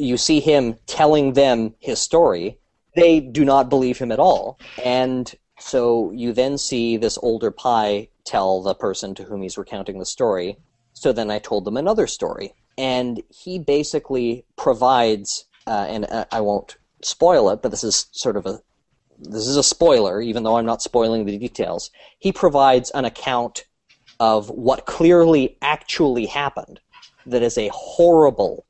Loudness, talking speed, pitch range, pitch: -19 LUFS, 165 wpm, 110-140 Hz, 125 Hz